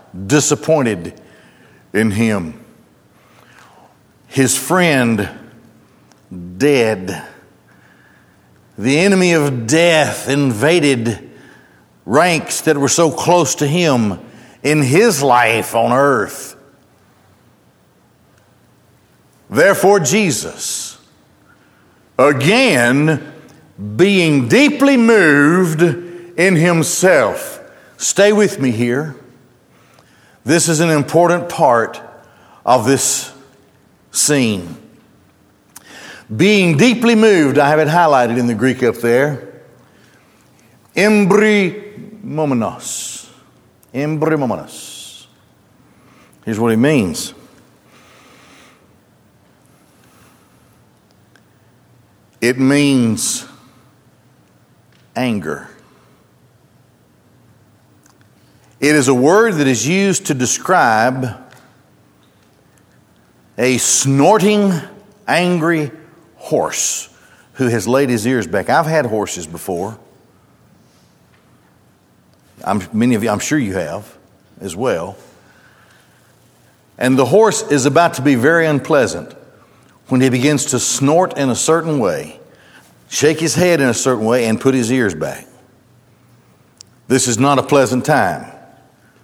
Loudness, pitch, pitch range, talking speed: -14 LUFS, 140 Hz, 120-170 Hz, 90 wpm